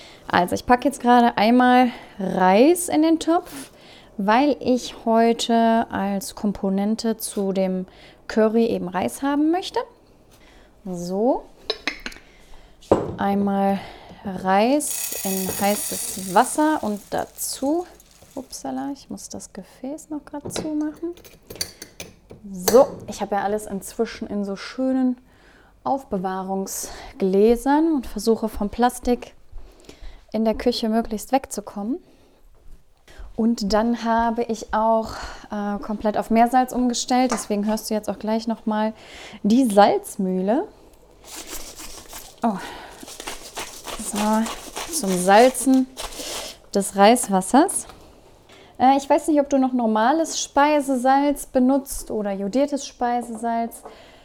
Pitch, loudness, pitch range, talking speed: 230 Hz, -21 LUFS, 205-270 Hz, 105 wpm